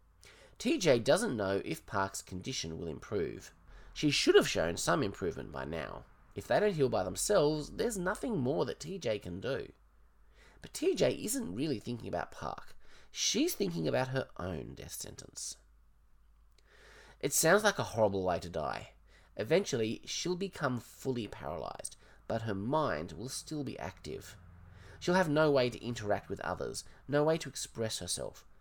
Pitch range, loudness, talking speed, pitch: 90-145 Hz, -34 LUFS, 160 wpm, 120 Hz